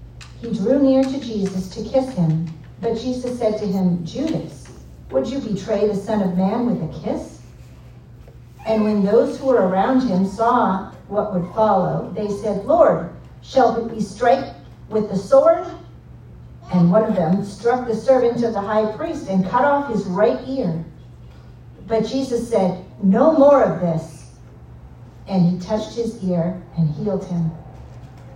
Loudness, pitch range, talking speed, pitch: -19 LUFS, 185-240 Hz, 165 wpm, 210 Hz